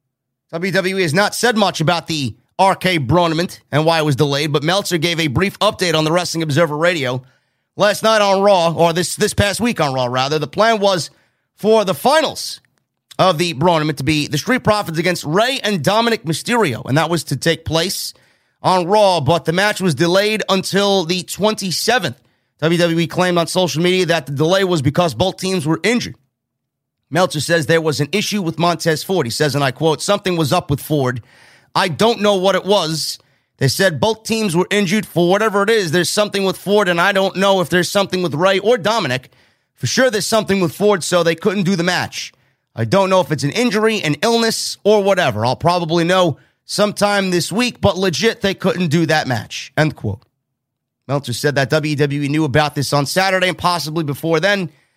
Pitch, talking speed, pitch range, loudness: 175 Hz, 205 wpm, 150-195 Hz, -16 LUFS